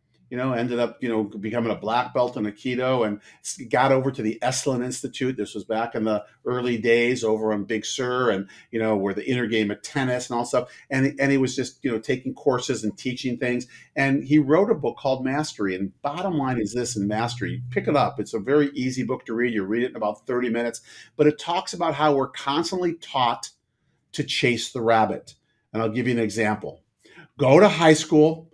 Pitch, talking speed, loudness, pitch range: 125 Hz, 225 wpm, -24 LUFS, 110-135 Hz